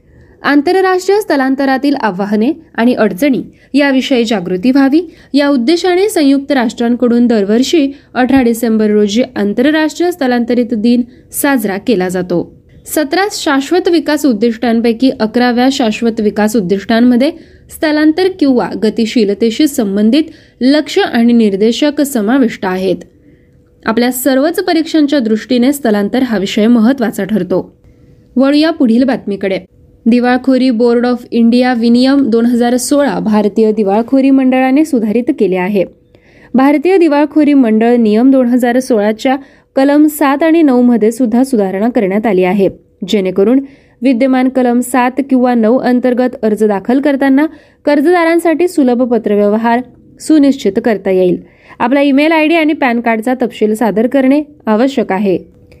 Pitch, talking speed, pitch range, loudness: 250 Hz, 120 wpm, 225-285 Hz, -11 LUFS